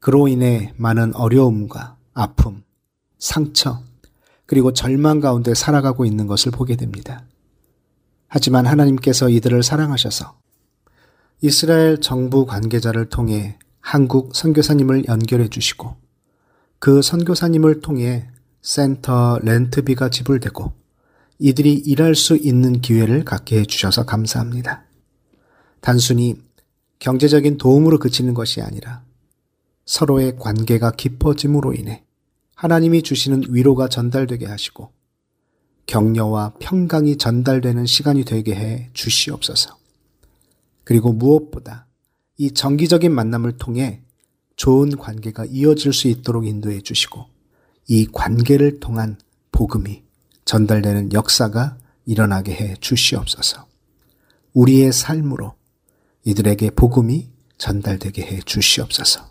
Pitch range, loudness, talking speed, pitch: 115-140 Hz, -17 LUFS, 275 characters per minute, 125 Hz